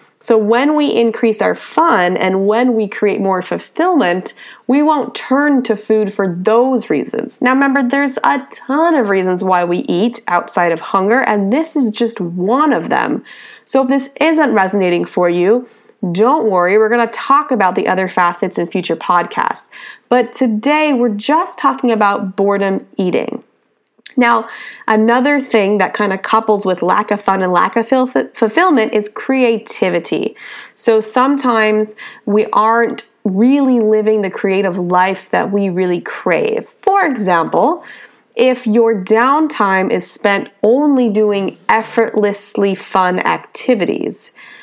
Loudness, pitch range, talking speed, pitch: -14 LUFS, 195-255 Hz, 150 wpm, 220 Hz